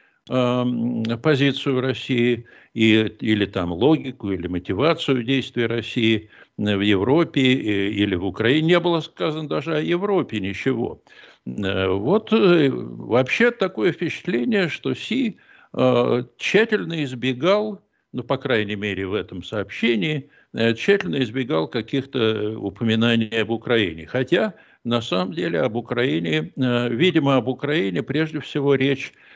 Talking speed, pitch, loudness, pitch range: 115 wpm, 125 Hz, -21 LUFS, 105-145 Hz